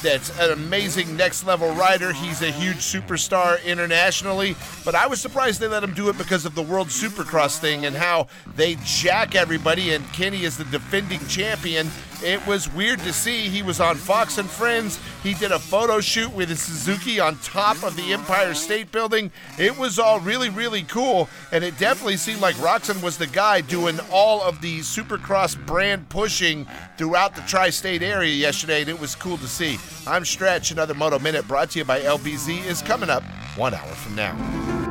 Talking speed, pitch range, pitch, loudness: 195 wpm, 165-200 Hz, 180 Hz, -21 LUFS